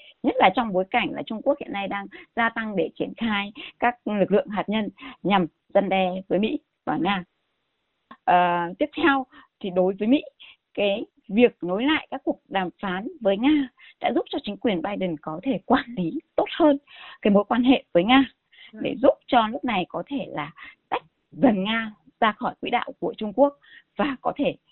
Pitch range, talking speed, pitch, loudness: 200-280 Hz, 205 wpm, 245 Hz, -24 LUFS